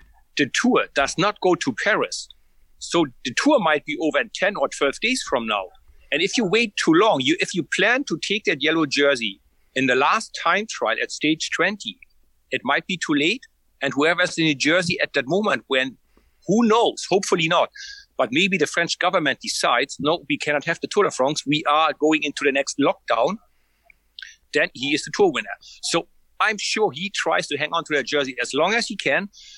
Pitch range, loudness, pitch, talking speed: 145-220 Hz, -21 LUFS, 170 Hz, 210 wpm